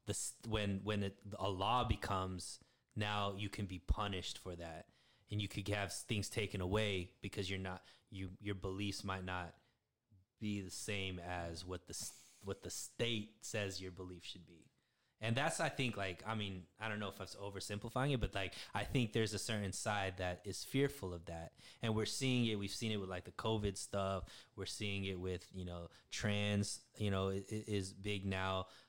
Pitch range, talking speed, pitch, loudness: 95-110 Hz, 205 wpm, 100 Hz, -42 LUFS